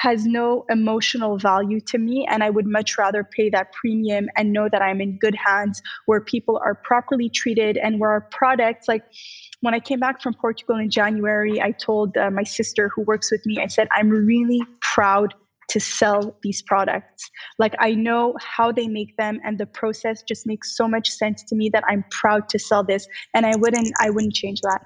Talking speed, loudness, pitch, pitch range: 210 wpm, -21 LUFS, 220 Hz, 210-230 Hz